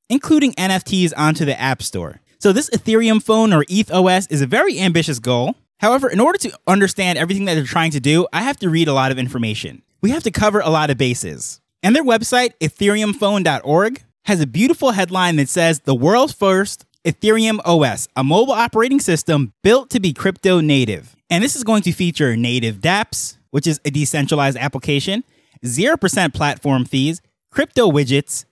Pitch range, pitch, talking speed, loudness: 140-210 Hz, 170 Hz, 180 wpm, -16 LUFS